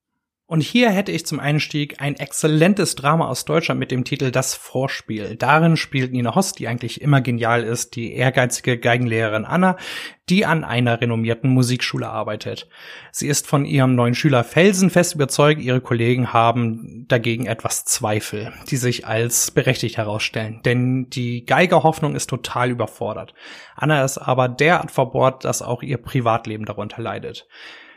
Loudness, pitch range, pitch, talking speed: -19 LUFS, 115-150 Hz, 125 Hz, 150 wpm